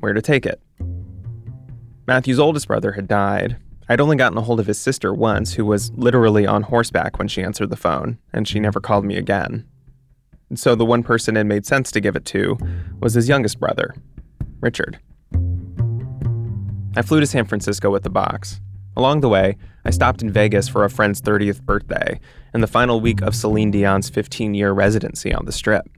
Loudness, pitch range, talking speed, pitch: -19 LUFS, 100-120 Hz, 195 wpm, 105 Hz